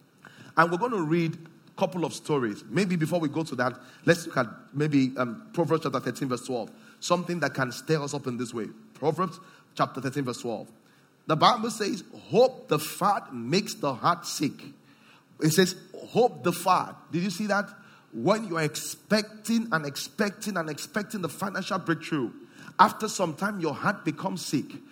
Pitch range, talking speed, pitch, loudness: 145-195 Hz, 180 wpm, 165 Hz, -28 LUFS